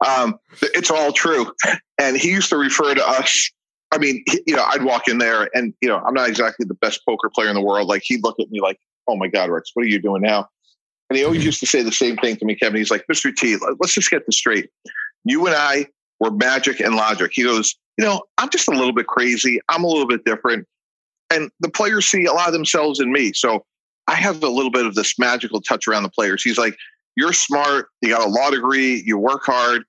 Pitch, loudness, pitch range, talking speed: 125 Hz, -18 LUFS, 110-160 Hz, 255 wpm